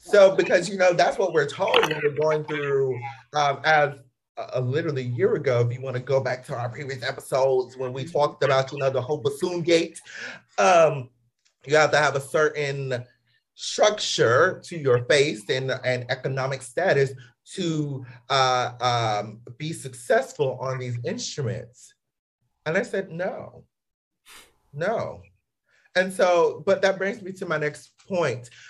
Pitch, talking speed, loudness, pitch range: 140 Hz, 165 wpm, -24 LUFS, 130-160 Hz